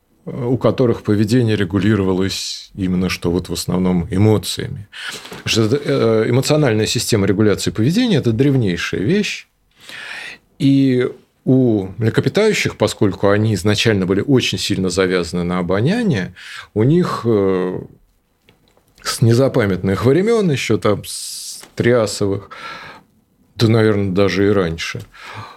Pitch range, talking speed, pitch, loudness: 95-130 Hz, 100 wpm, 110 Hz, -17 LUFS